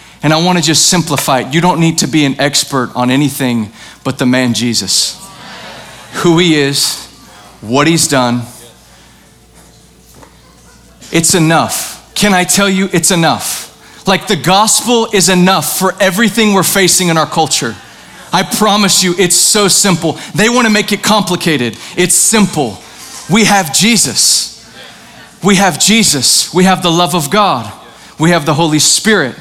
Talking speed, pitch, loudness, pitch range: 155 wpm, 175 Hz, -10 LUFS, 145-195 Hz